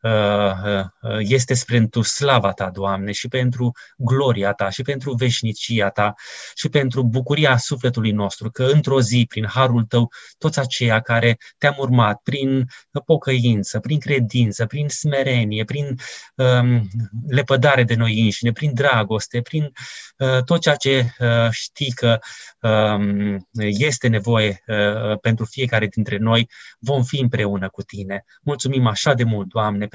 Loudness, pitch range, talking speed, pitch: -19 LUFS, 110-135 Hz, 140 wpm, 120 Hz